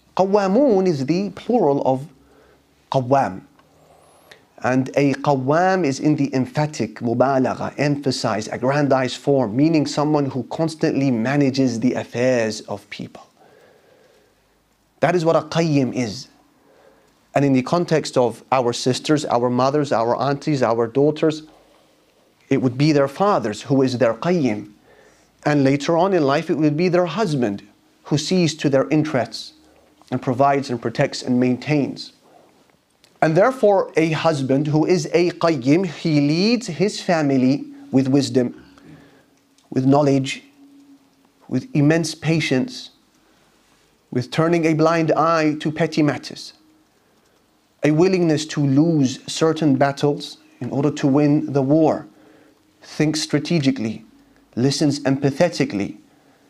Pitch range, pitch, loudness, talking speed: 130-160 Hz, 145 Hz, -19 LUFS, 125 wpm